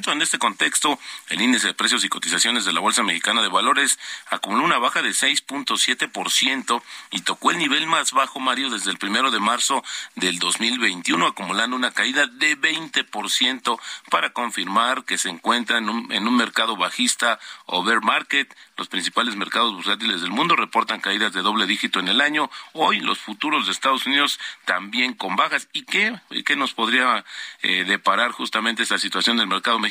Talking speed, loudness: 175 wpm, -20 LUFS